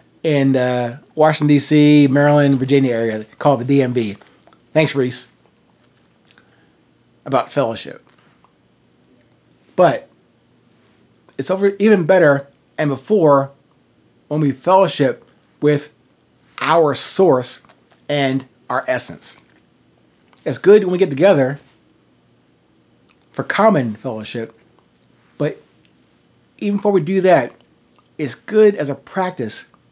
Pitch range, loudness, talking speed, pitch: 125-155 Hz, -16 LUFS, 100 wpm, 140 Hz